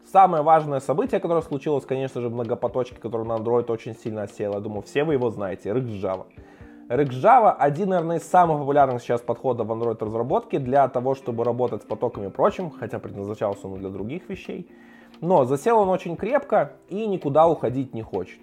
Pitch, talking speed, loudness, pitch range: 130 Hz, 185 wpm, -23 LUFS, 115-170 Hz